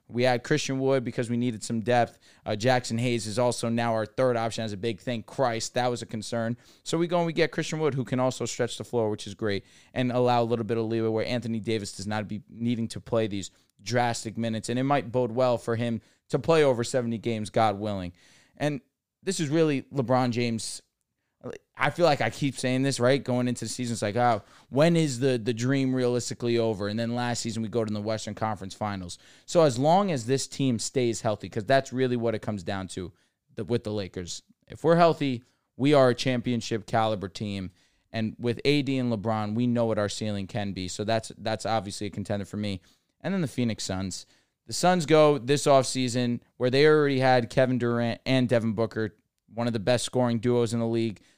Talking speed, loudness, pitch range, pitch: 225 wpm, -27 LUFS, 110-130 Hz, 120 Hz